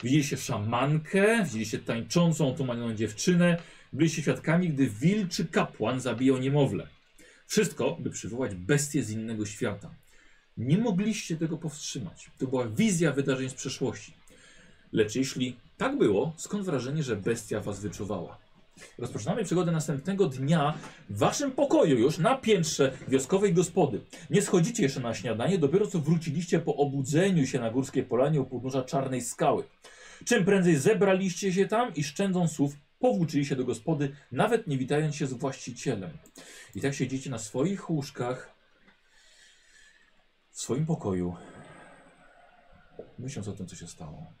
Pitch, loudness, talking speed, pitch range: 145 Hz, -28 LUFS, 140 wpm, 130-175 Hz